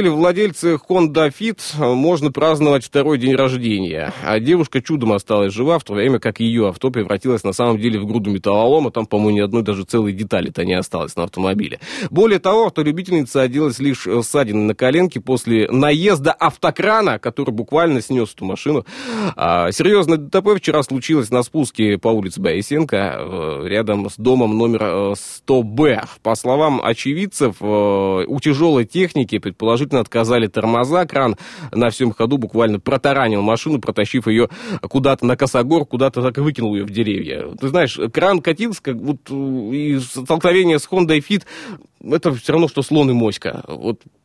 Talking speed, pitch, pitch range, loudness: 155 wpm, 130 Hz, 110-155 Hz, -17 LUFS